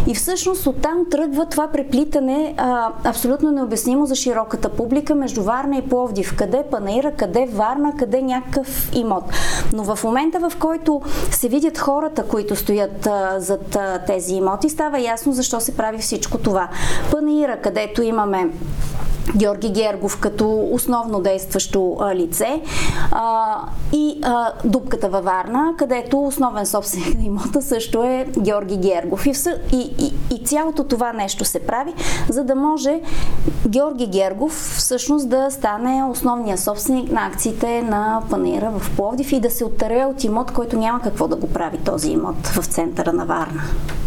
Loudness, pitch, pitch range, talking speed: -20 LUFS, 245 Hz, 210-280 Hz, 155 wpm